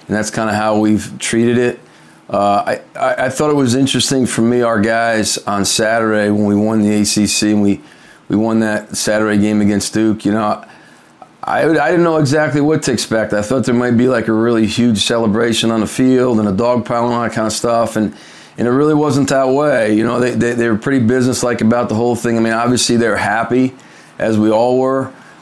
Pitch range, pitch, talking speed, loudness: 105-125 Hz, 115 Hz, 230 wpm, -14 LUFS